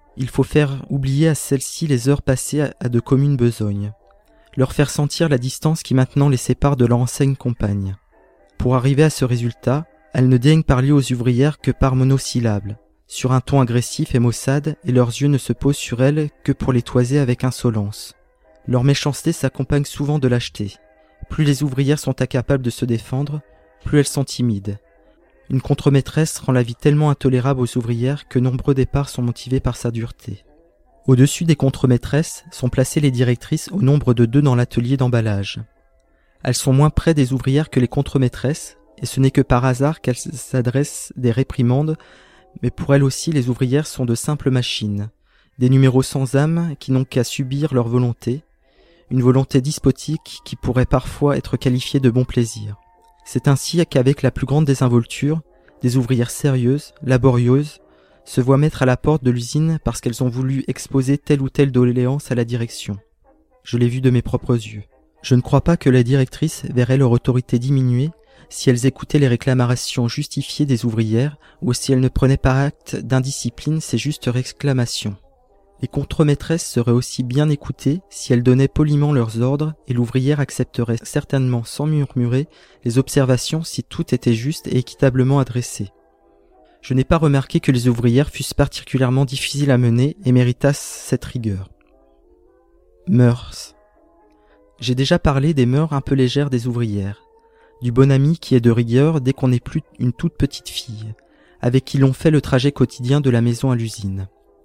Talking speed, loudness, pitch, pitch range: 175 wpm, -18 LUFS, 130 Hz, 125-145 Hz